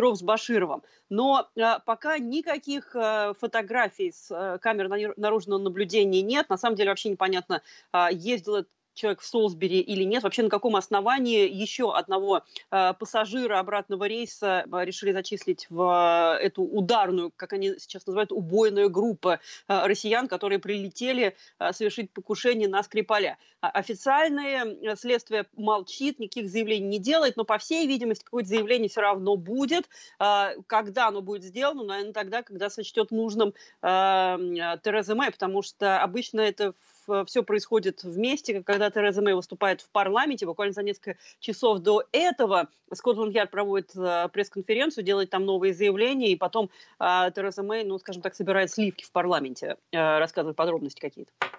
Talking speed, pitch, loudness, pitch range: 150 wpm, 205 Hz, -26 LUFS, 195-225 Hz